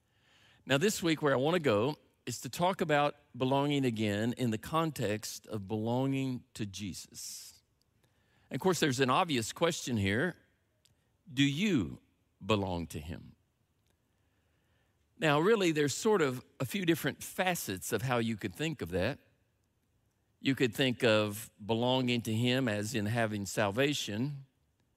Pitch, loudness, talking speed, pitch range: 120 Hz, -32 LUFS, 145 wpm, 105-140 Hz